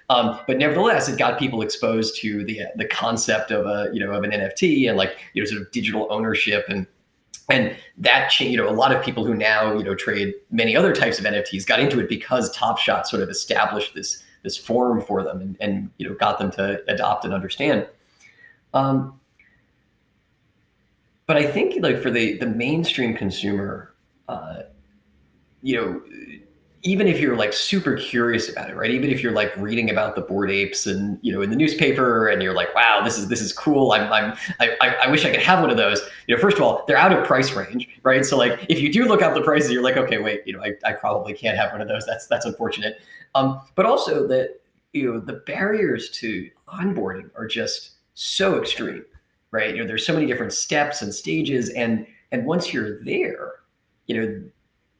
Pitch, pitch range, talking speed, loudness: 110 Hz, 100-135 Hz, 215 wpm, -21 LUFS